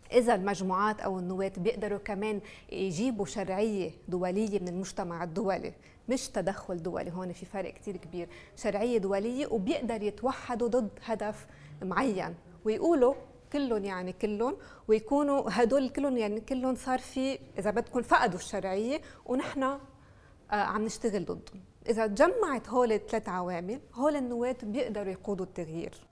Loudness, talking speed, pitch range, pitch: -32 LUFS, 130 wpm, 195-250 Hz, 215 Hz